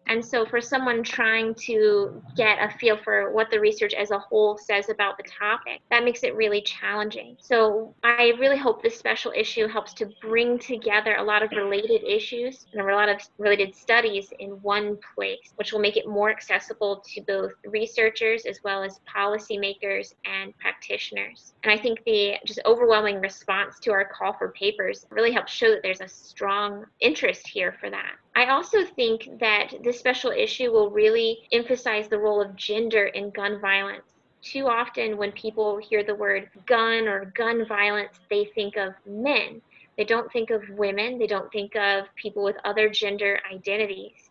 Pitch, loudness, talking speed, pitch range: 215 Hz, -24 LUFS, 180 wpm, 205-245 Hz